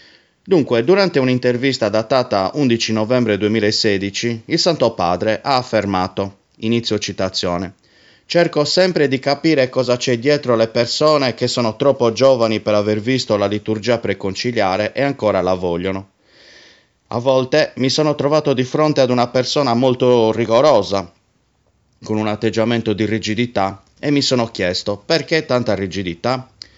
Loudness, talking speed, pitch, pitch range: -17 LUFS, 135 wpm, 115 Hz, 105-130 Hz